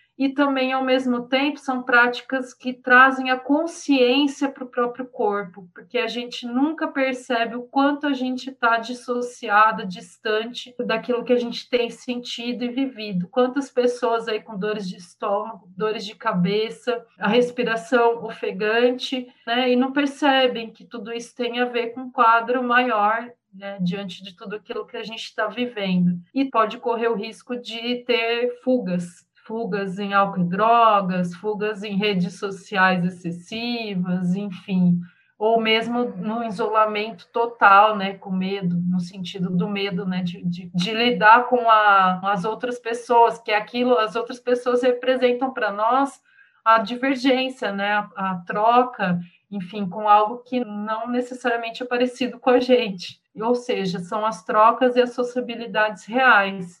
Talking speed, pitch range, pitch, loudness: 155 wpm, 205-245 Hz, 230 Hz, -21 LUFS